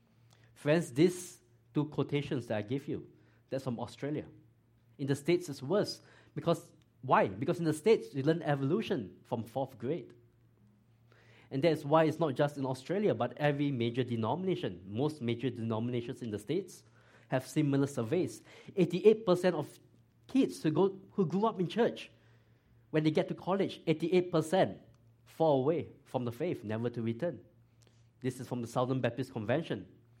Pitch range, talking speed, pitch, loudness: 115-160 Hz, 160 wpm, 130 Hz, -33 LUFS